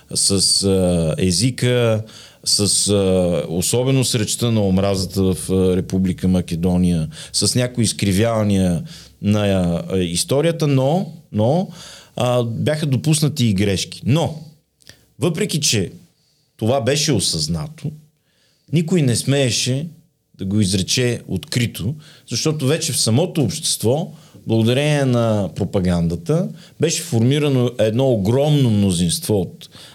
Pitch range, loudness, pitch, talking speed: 100-150 Hz, -18 LUFS, 125 Hz, 95 wpm